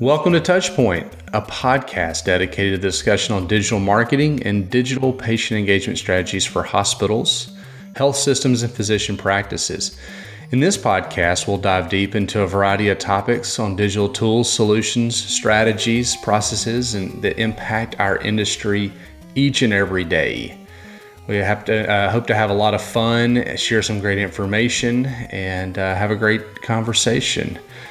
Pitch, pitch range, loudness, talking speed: 105 Hz, 100-120 Hz, -18 LUFS, 150 wpm